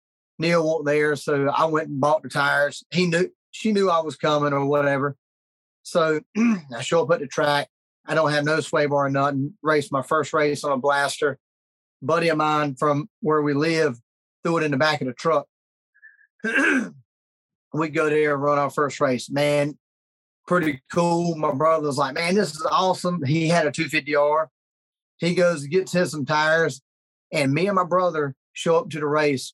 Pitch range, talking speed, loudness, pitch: 140-165 Hz, 195 wpm, -22 LUFS, 150 Hz